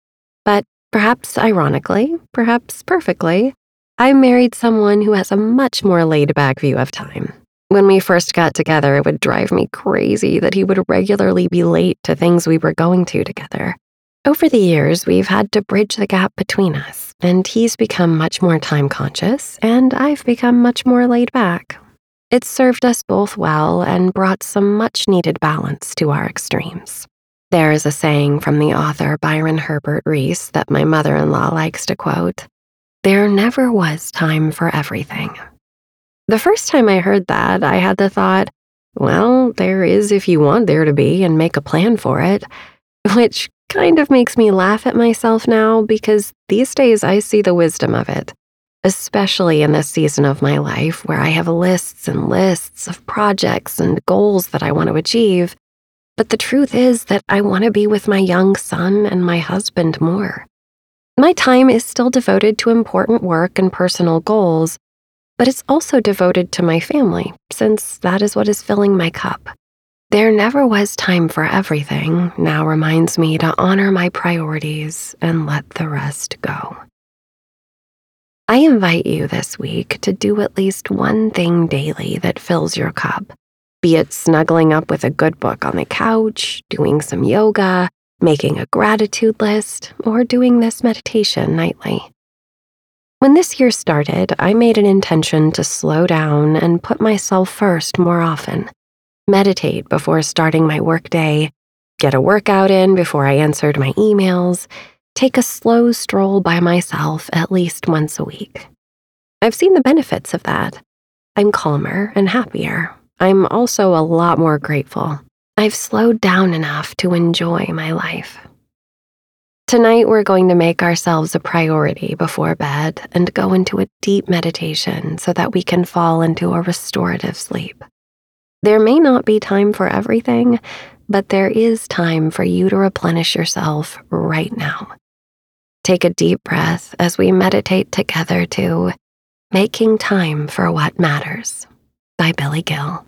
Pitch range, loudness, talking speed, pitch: 160-215 Hz, -15 LUFS, 165 wpm, 185 Hz